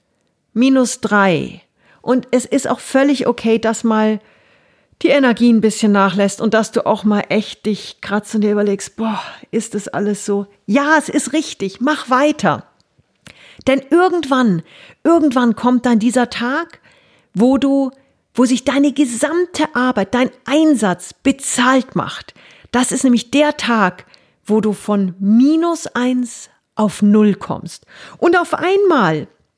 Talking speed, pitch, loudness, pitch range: 140 wpm, 240 Hz, -16 LUFS, 210-275 Hz